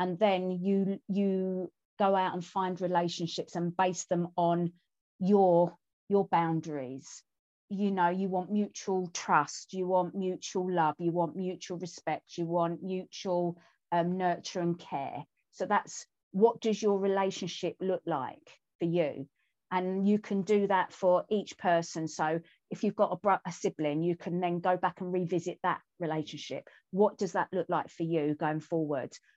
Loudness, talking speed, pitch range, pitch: -31 LUFS, 165 wpm, 170-195 Hz, 180 Hz